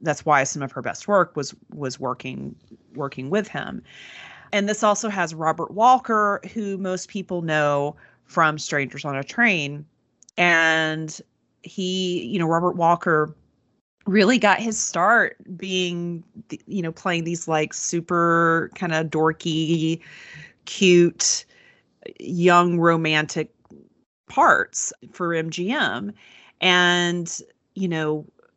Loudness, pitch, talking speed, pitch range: -21 LUFS, 170 Hz, 120 wpm, 155-195 Hz